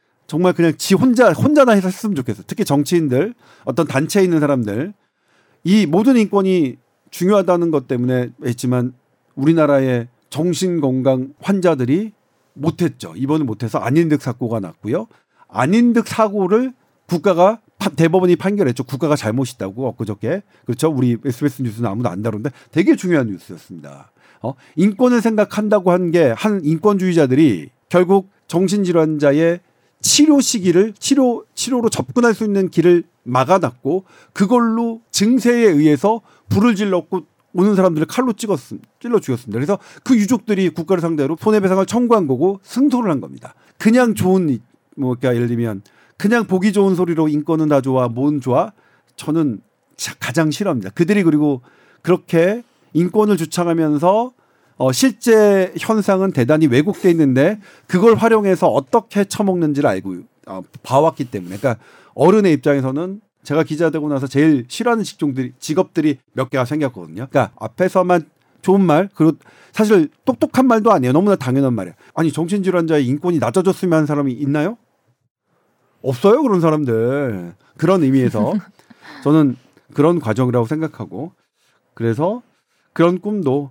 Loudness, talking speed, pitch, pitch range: -16 LUFS, 345 characters per minute, 170 Hz, 135-200 Hz